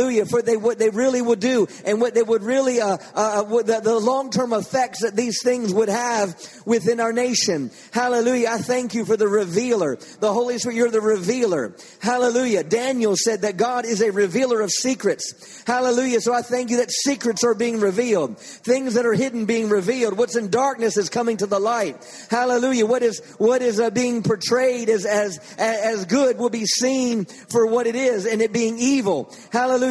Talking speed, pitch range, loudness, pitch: 200 wpm, 220-245 Hz, -20 LUFS, 235 Hz